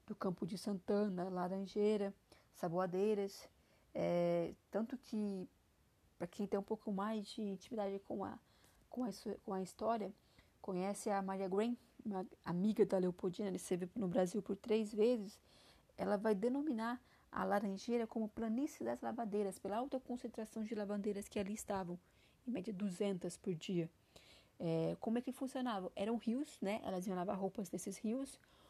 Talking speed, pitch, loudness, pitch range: 155 wpm, 205 Hz, -41 LUFS, 190-225 Hz